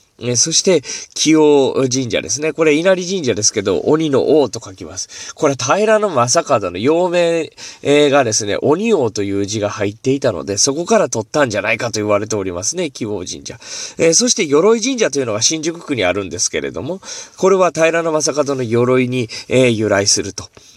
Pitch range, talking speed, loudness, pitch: 110-165 Hz, 365 characters per minute, -15 LUFS, 140 Hz